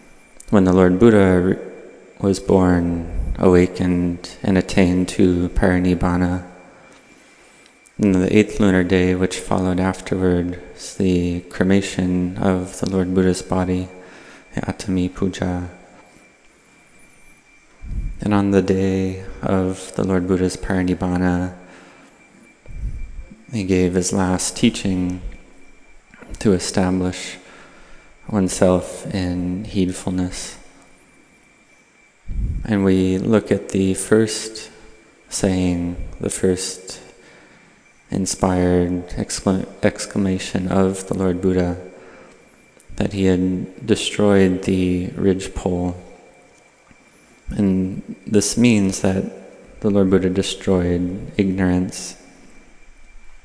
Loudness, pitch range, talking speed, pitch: -19 LUFS, 90-95 Hz, 90 wpm, 95 Hz